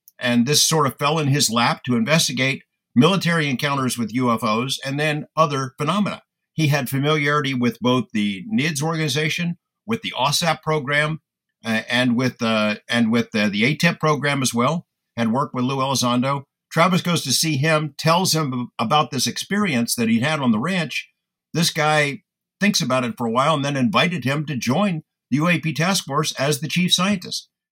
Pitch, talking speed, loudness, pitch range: 150 Hz, 185 wpm, -20 LUFS, 125-165 Hz